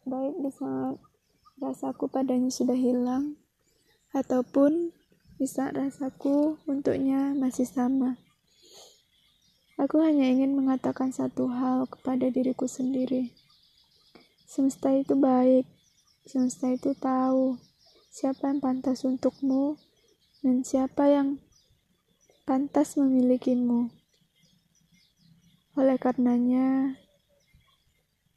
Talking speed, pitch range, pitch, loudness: 80 wpm, 255-275 Hz, 260 Hz, -27 LUFS